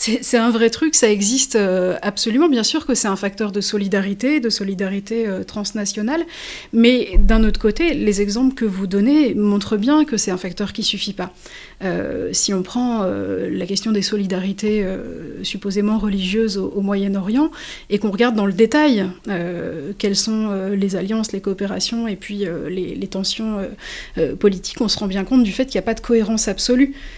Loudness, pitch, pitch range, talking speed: -19 LUFS, 210 Hz, 195-230 Hz, 205 wpm